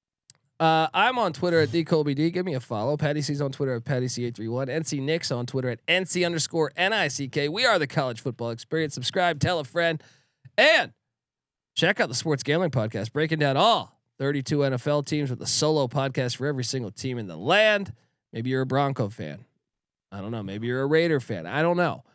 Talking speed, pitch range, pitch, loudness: 205 wpm, 125-160 Hz, 140 Hz, -25 LUFS